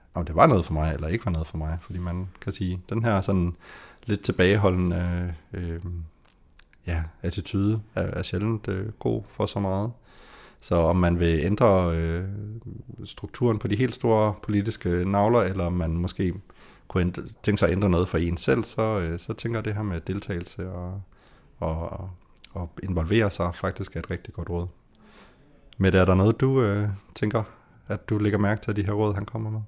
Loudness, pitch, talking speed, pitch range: -26 LUFS, 95 Hz, 195 wpm, 85-105 Hz